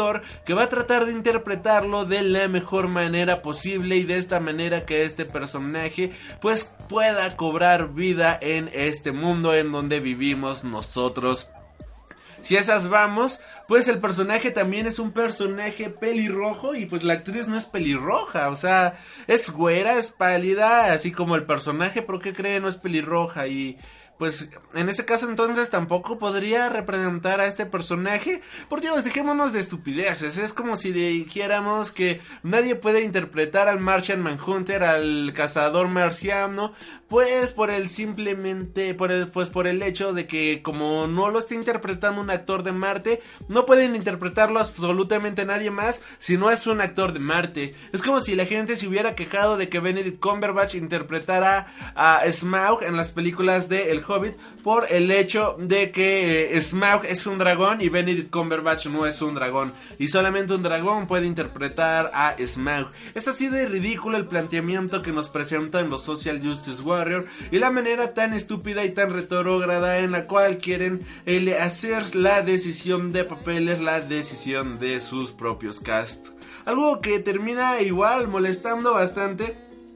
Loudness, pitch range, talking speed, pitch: -23 LUFS, 165-210 Hz, 165 wpm, 185 Hz